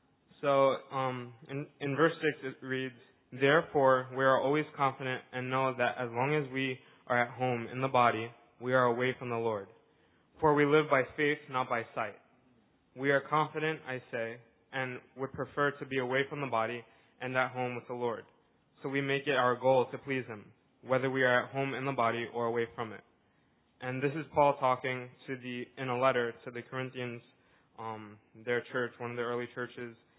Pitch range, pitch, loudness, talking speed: 120-135 Hz, 130 Hz, -32 LUFS, 205 wpm